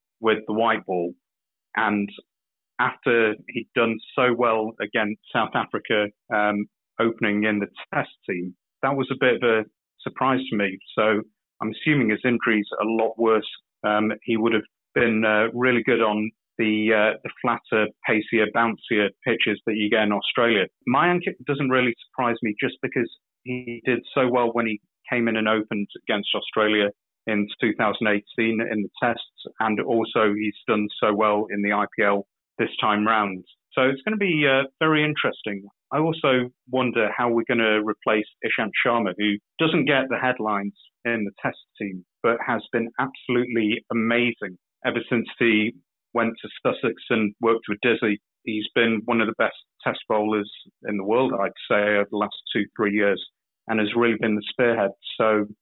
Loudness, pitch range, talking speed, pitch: -23 LUFS, 105-120 Hz, 175 wpm, 110 Hz